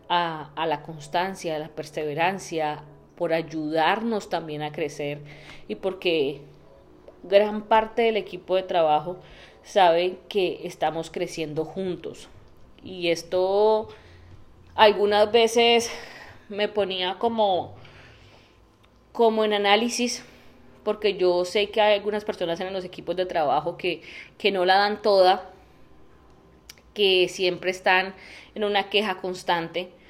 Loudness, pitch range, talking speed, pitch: -24 LUFS, 155-205 Hz, 120 wpm, 180 Hz